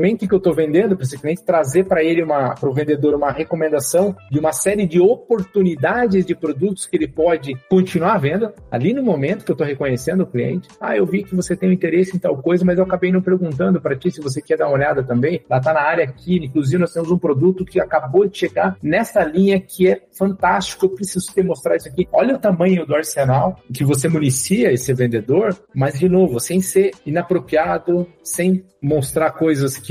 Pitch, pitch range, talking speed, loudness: 175 Hz, 150-185 Hz, 215 wpm, -18 LUFS